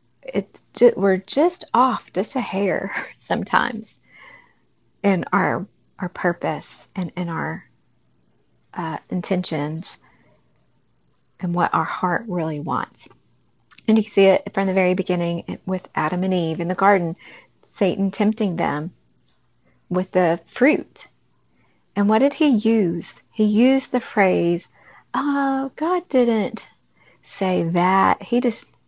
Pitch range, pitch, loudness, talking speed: 175-230 Hz, 190 Hz, -21 LUFS, 125 wpm